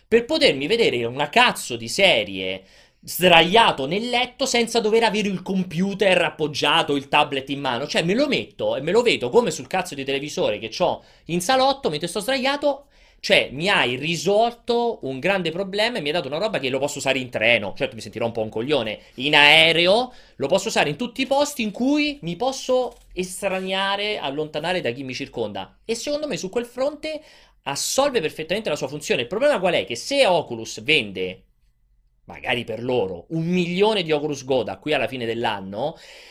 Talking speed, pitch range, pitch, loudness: 190 wpm, 145-240 Hz, 185 Hz, -21 LUFS